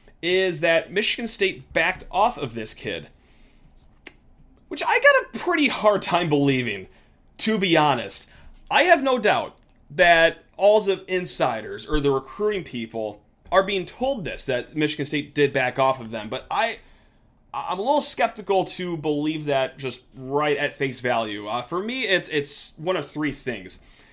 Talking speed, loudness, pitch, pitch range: 165 wpm, -22 LUFS, 150 Hz, 130-190 Hz